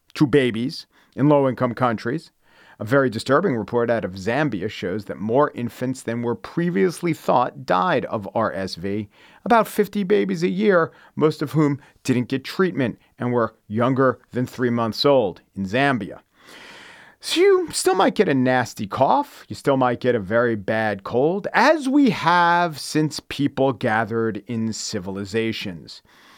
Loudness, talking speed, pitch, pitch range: -21 LUFS, 155 wpm, 130 Hz, 115-170 Hz